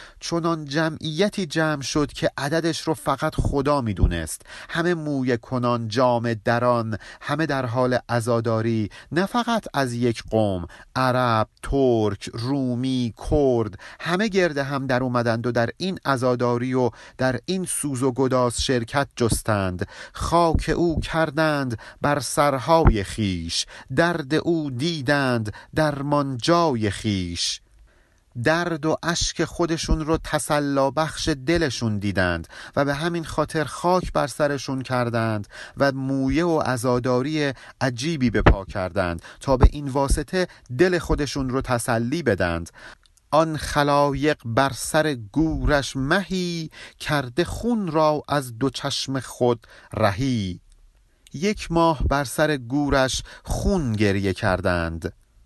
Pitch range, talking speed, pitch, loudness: 115-155 Hz, 120 wpm, 135 Hz, -23 LUFS